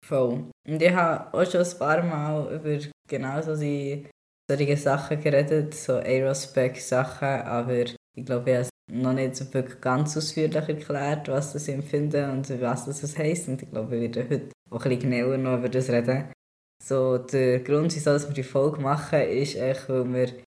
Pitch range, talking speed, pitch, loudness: 130-150 Hz, 180 wpm, 135 Hz, -26 LUFS